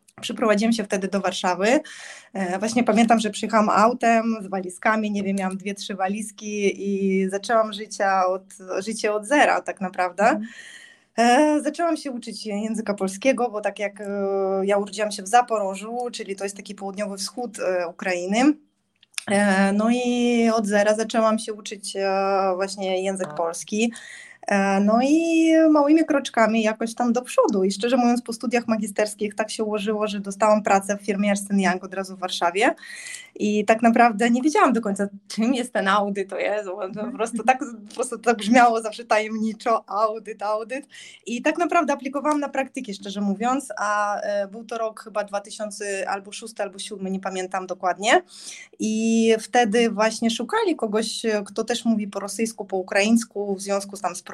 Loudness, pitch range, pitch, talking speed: -22 LUFS, 200-235 Hz, 215 Hz, 165 wpm